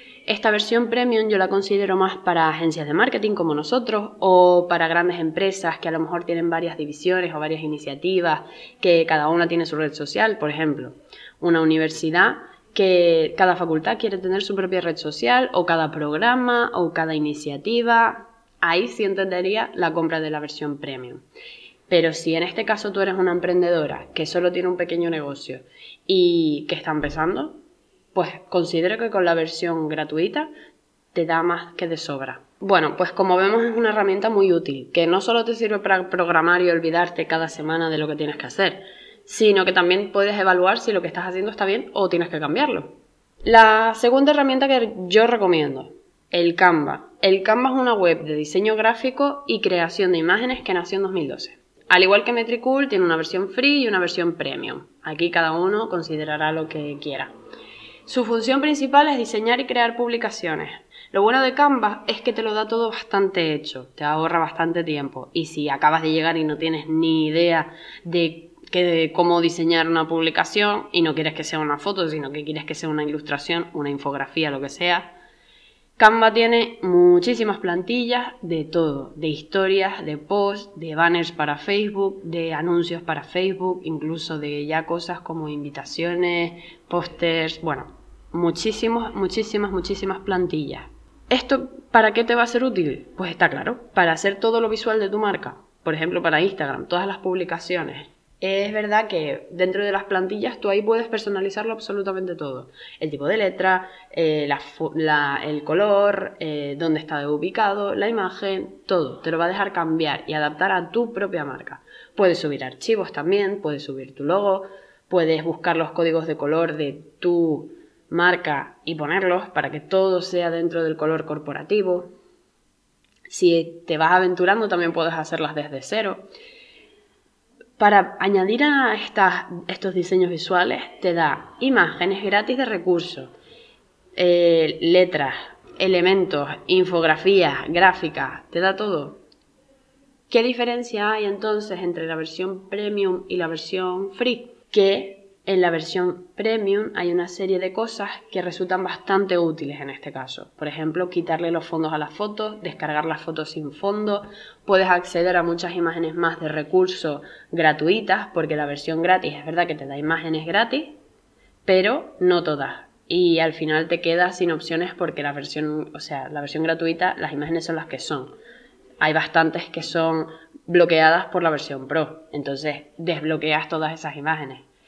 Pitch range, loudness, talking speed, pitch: 160-200 Hz, -21 LUFS, 170 wpm, 175 Hz